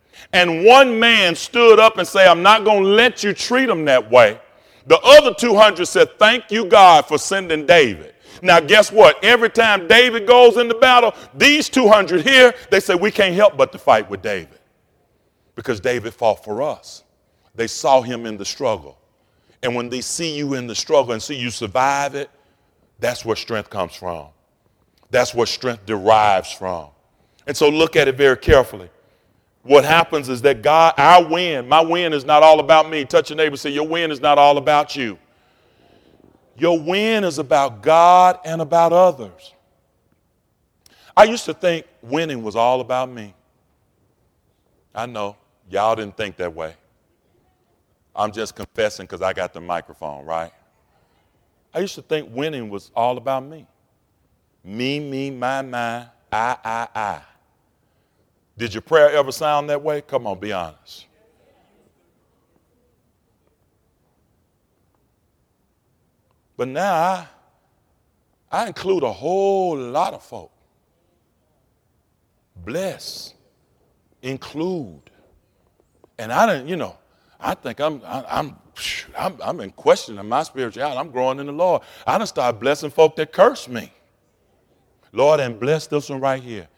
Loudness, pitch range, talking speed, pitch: -16 LUFS, 115-180 Hz, 155 wpm, 145 Hz